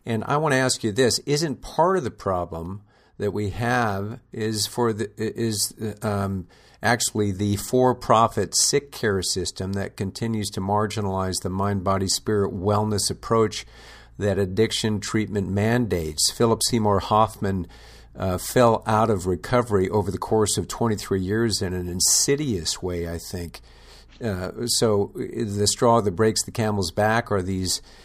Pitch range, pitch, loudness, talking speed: 95-115 Hz, 105 Hz, -23 LUFS, 150 wpm